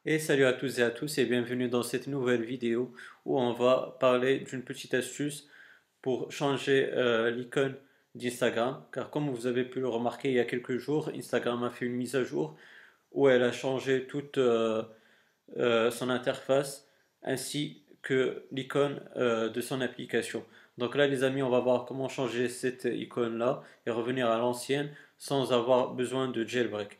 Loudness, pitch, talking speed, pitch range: -30 LUFS, 125 Hz, 180 wpm, 120-135 Hz